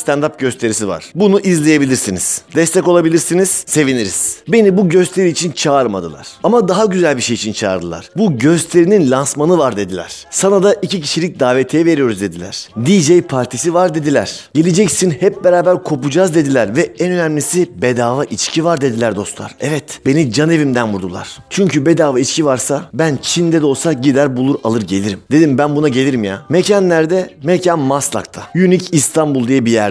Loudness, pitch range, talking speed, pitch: -13 LUFS, 125-175 Hz, 160 wpm, 150 Hz